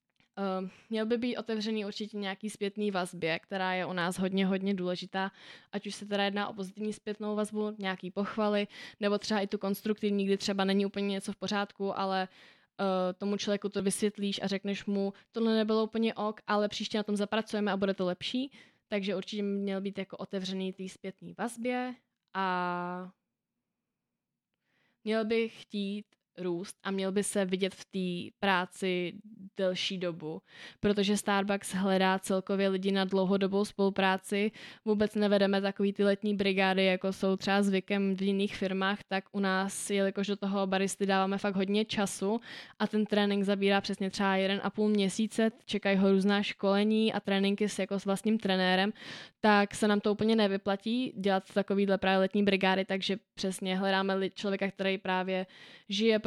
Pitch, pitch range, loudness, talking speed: 200 Hz, 190-210 Hz, -31 LUFS, 165 wpm